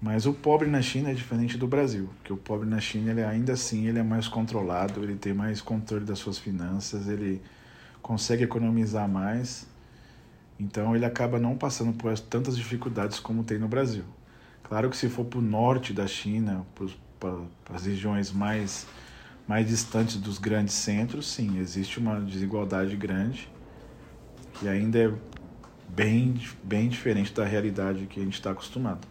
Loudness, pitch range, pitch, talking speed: -29 LUFS, 100-115 Hz, 110 Hz, 165 wpm